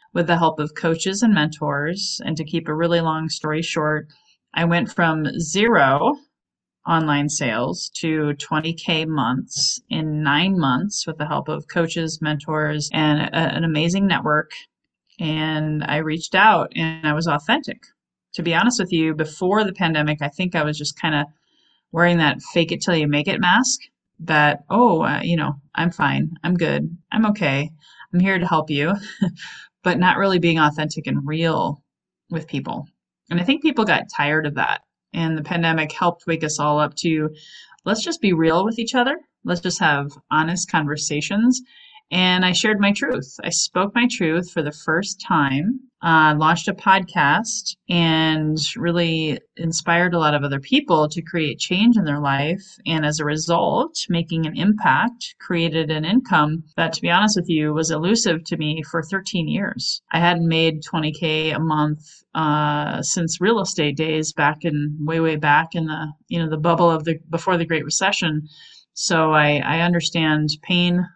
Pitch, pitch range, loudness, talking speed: 165 Hz, 155-185 Hz, -20 LUFS, 180 wpm